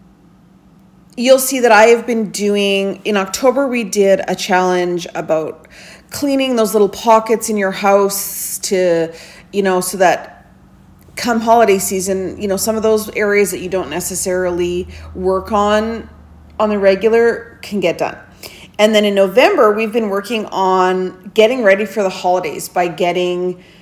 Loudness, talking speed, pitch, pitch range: -15 LUFS, 155 wpm, 195 Hz, 180-215 Hz